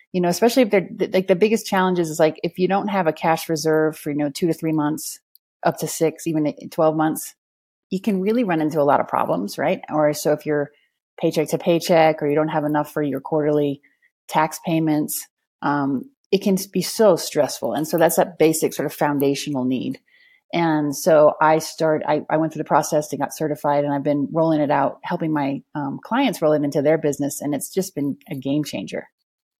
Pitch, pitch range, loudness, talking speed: 155 Hz, 150-175 Hz, -21 LUFS, 220 wpm